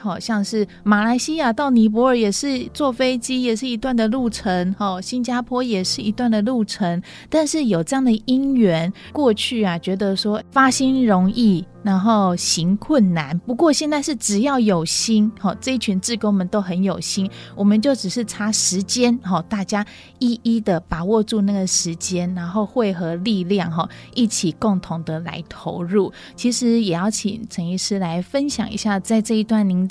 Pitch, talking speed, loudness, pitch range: 215 Hz, 255 characters per minute, -19 LUFS, 190-240 Hz